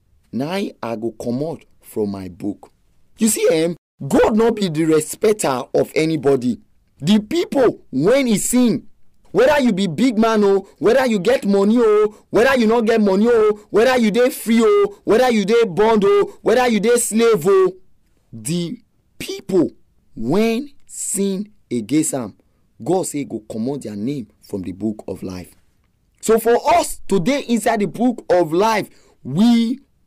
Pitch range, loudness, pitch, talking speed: 155-235 Hz, -17 LUFS, 210 Hz, 180 wpm